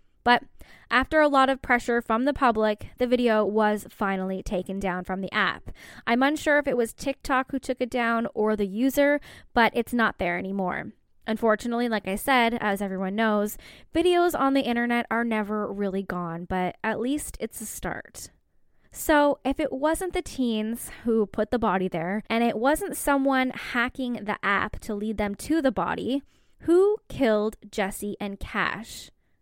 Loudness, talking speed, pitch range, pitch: -25 LUFS, 175 wpm, 210-265 Hz, 230 Hz